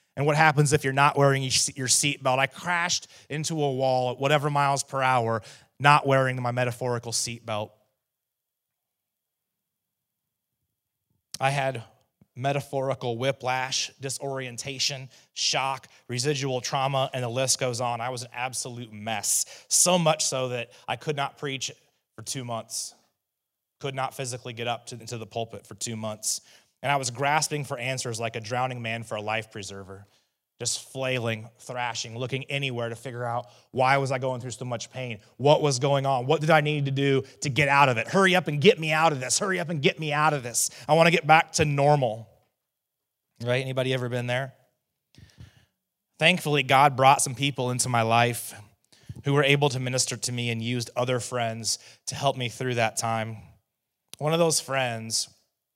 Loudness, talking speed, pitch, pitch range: -25 LUFS, 180 wpm, 130 Hz, 120-140 Hz